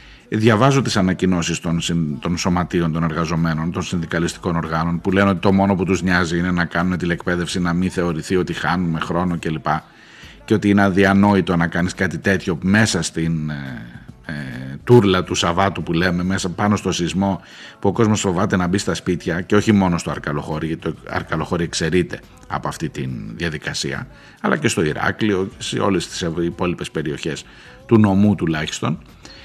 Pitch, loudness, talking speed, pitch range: 90 Hz, -19 LUFS, 165 wpm, 85-100 Hz